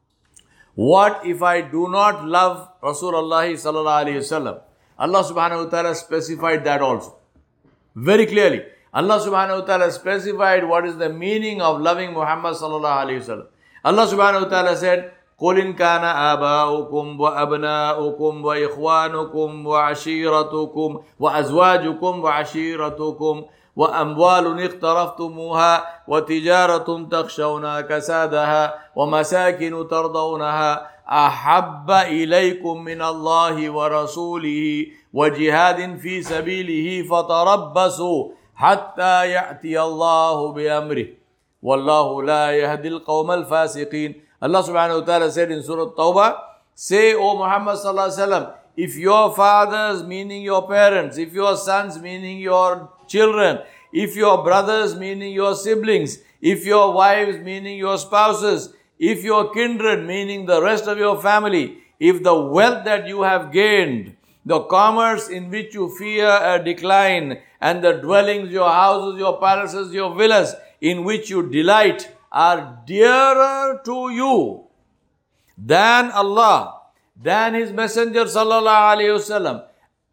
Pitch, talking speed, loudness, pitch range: 180 Hz, 110 wpm, -18 LUFS, 160-200 Hz